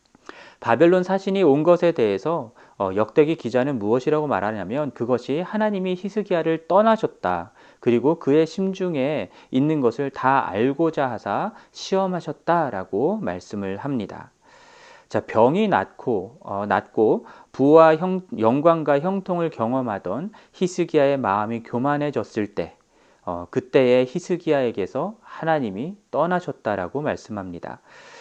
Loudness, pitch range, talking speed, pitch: -22 LUFS, 125-185 Hz, 285 characters per minute, 155 Hz